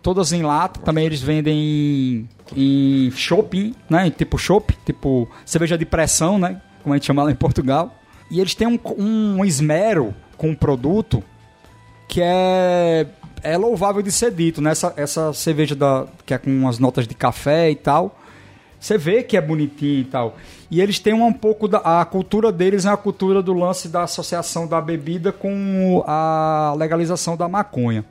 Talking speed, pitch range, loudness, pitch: 185 wpm, 145-190 Hz, -19 LUFS, 165 Hz